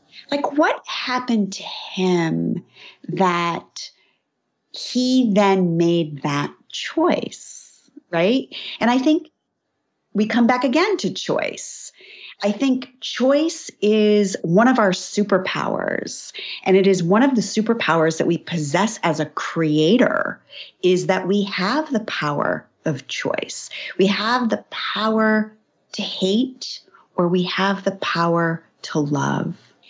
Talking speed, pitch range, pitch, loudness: 125 wpm, 180-250 Hz, 205 Hz, -20 LUFS